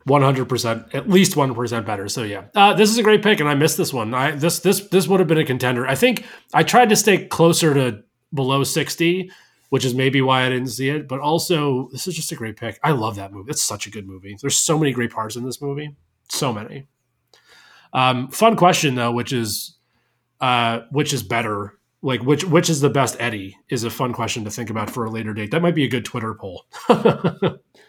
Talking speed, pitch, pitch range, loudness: 235 wpm, 130 Hz, 115-160 Hz, -19 LUFS